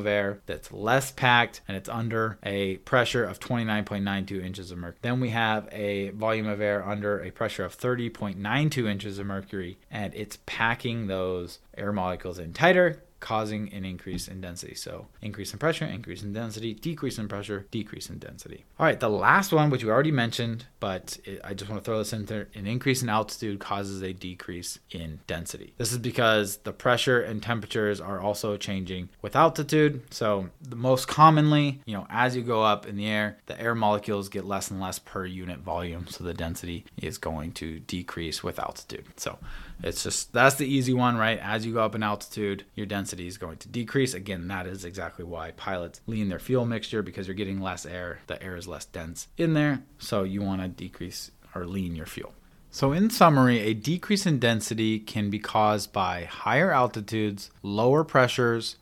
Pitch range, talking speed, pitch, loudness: 95-120 Hz, 195 wpm, 105 Hz, -27 LUFS